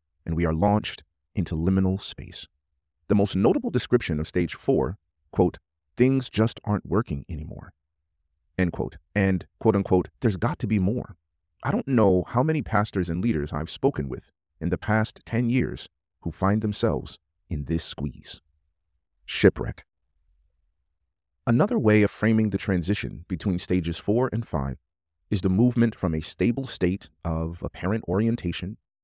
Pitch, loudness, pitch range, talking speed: 90 Hz, -25 LUFS, 80-105 Hz, 155 wpm